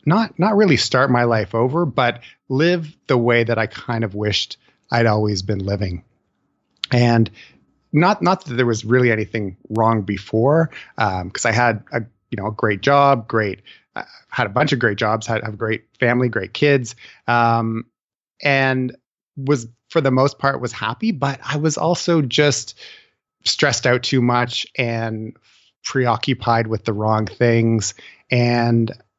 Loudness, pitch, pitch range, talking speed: -19 LUFS, 120 Hz, 110-135 Hz, 165 wpm